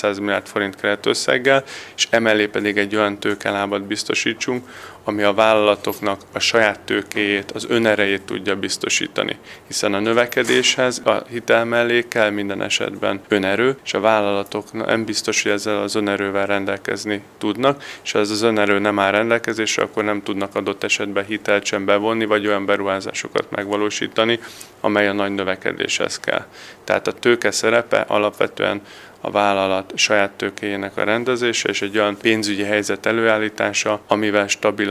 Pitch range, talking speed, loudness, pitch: 100-110 Hz, 150 wpm, -19 LUFS, 105 Hz